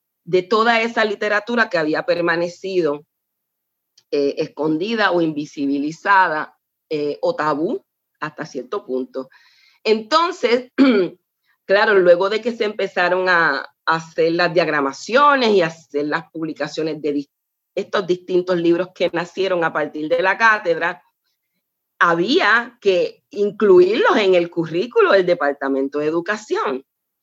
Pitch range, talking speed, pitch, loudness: 155-215 Hz, 115 wpm, 175 Hz, -18 LUFS